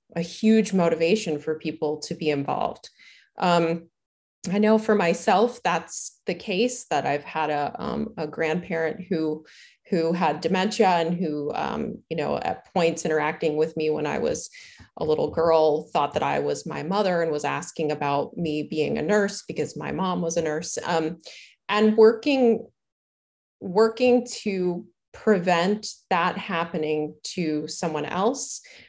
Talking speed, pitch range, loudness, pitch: 155 wpm, 155-210 Hz, -24 LUFS, 170 Hz